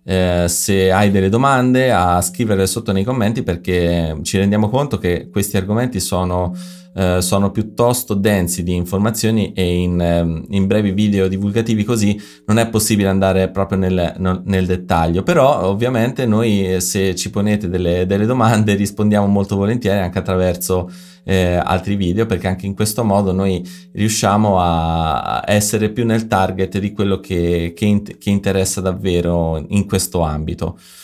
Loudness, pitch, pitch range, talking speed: -16 LUFS, 95 Hz, 90-105 Hz, 150 wpm